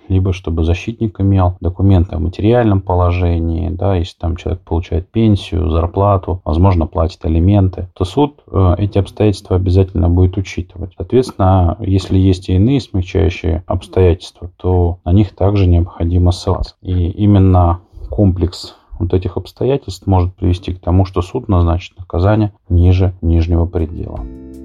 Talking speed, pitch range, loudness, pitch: 135 wpm, 85-100 Hz, -15 LUFS, 90 Hz